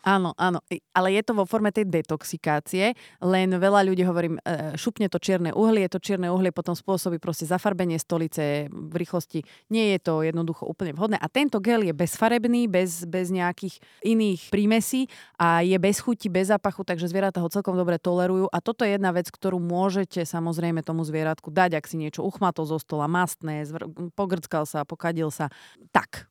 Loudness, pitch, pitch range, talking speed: -25 LUFS, 180 Hz, 165-195 Hz, 180 wpm